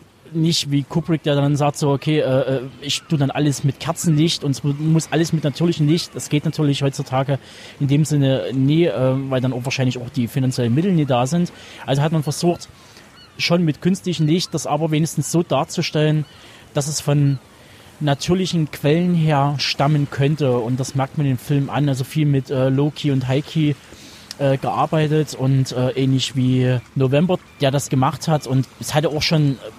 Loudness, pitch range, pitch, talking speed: -19 LUFS, 130-155 Hz, 140 Hz, 185 wpm